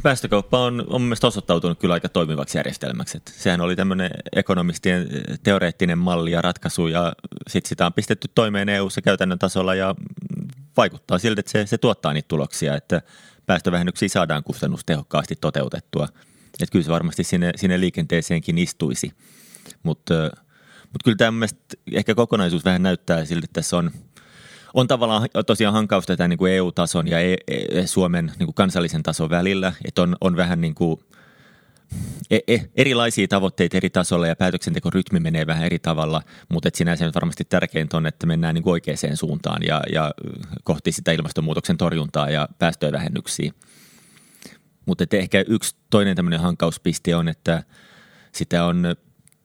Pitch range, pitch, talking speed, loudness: 85-105 Hz, 90 Hz, 145 wpm, -21 LUFS